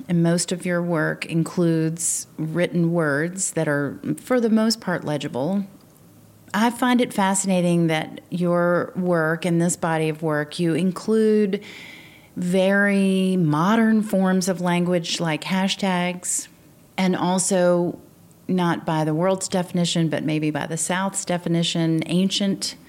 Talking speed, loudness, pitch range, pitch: 130 wpm, -22 LUFS, 165-190 Hz, 175 Hz